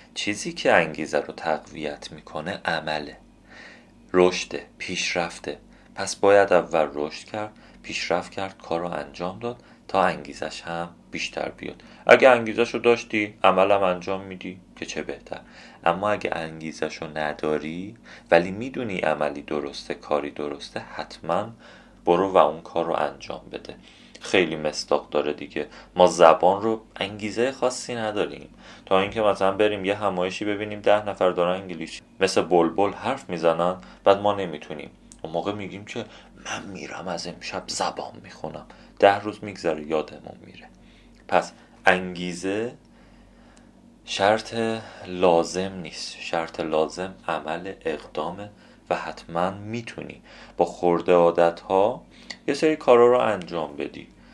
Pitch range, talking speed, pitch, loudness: 85-105 Hz, 130 wpm, 95 Hz, -24 LUFS